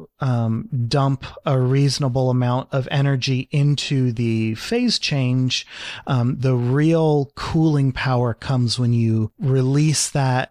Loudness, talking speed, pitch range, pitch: -20 LUFS, 120 wpm, 125-140 Hz, 130 Hz